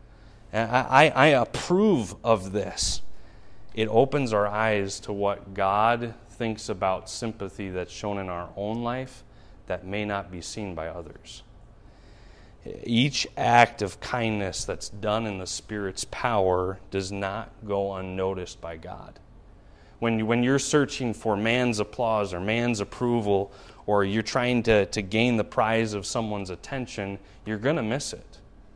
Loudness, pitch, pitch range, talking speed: -26 LUFS, 105 Hz, 95-115 Hz, 150 wpm